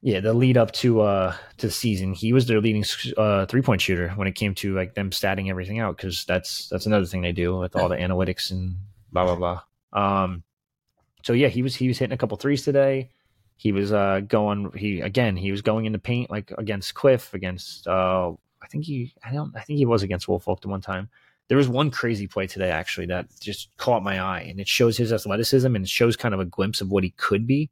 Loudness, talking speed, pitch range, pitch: -24 LUFS, 240 wpm, 95-120 Hz, 105 Hz